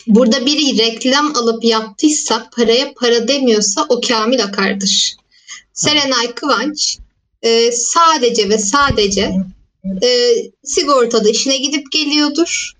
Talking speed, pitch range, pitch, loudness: 100 wpm, 225-295 Hz, 245 Hz, -13 LUFS